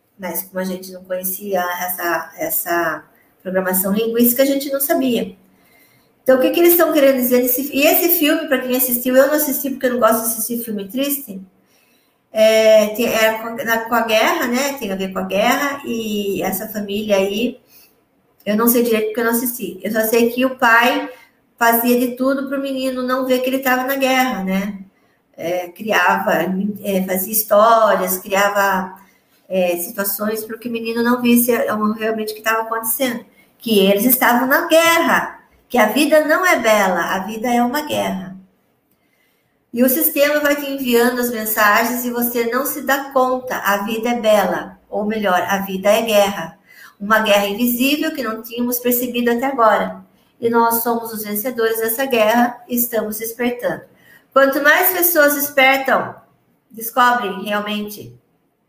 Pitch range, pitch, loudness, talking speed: 205-260 Hz, 230 Hz, -16 LUFS, 175 wpm